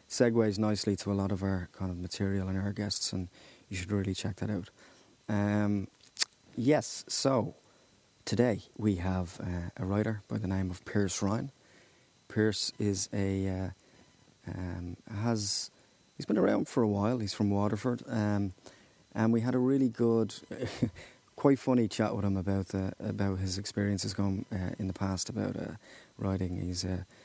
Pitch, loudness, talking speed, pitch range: 100 Hz, -32 LUFS, 170 wpm, 95-110 Hz